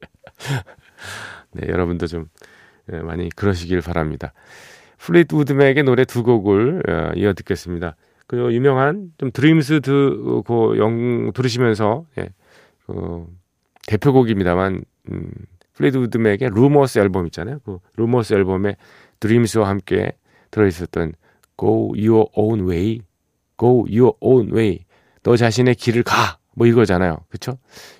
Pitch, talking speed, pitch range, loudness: 110 Hz, 290 characters per minute, 90-125 Hz, -18 LUFS